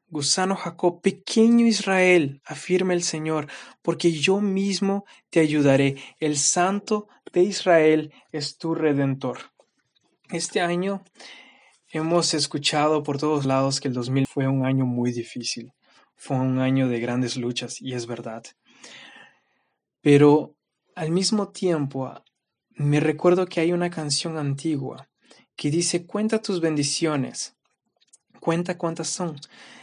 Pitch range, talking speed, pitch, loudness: 135-180 Hz, 125 wpm, 155 Hz, -23 LUFS